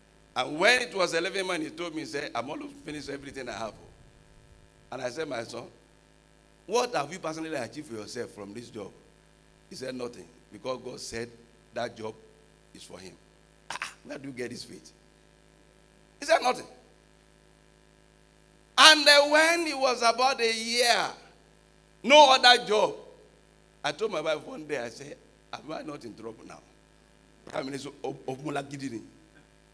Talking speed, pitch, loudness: 165 wpm, 160 Hz, -25 LUFS